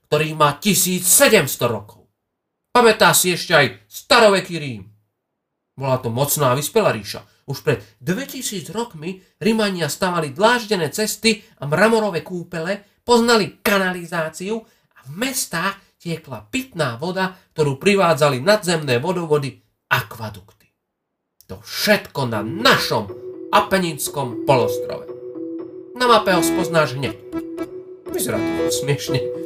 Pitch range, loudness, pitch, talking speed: 140-215 Hz, -18 LUFS, 170 Hz, 110 wpm